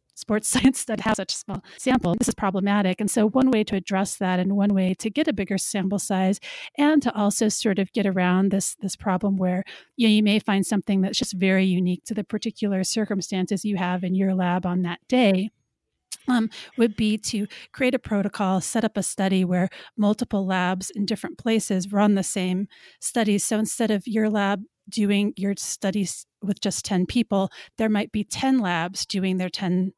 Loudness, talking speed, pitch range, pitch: -23 LUFS, 200 wpm, 190-220 Hz, 200 Hz